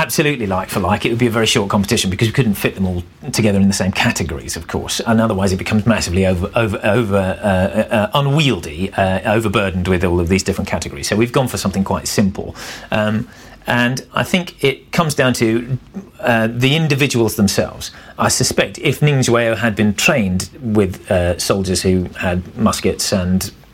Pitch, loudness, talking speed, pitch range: 105 Hz, -16 LUFS, 190 wpm, 95-120 Hz